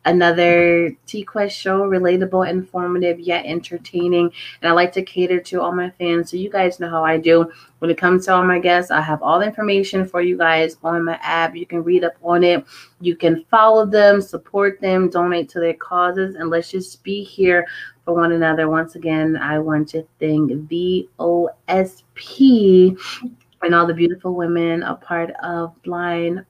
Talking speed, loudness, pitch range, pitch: 185 wpm, -17 LUFS, 165-185 Hz, 175 Hz